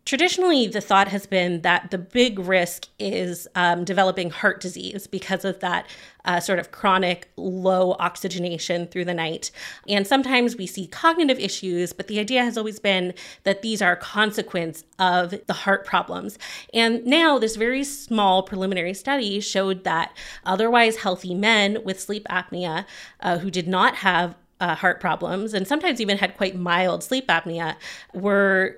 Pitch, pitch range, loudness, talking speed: 190 Hz, 180-215 Hz, -22 LUFS, 165 wpm